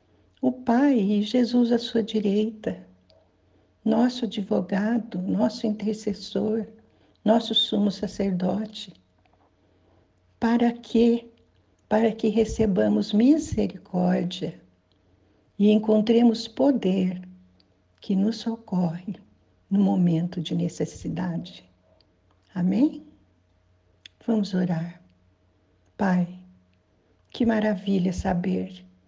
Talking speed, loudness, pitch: 75 wpm, -24 LUFS, 190 Hz